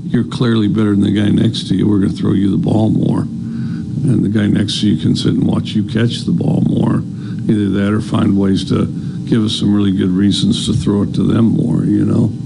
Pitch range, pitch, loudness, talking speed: 100-110 Hz, 105 Hz, -14 LUFS, 250 wpm